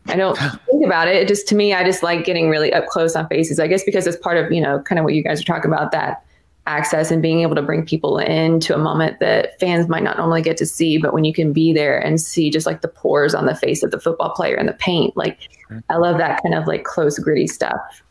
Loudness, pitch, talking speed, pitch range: -17 LUFS, 165 Hz, 275 wpm, 155-170 Hz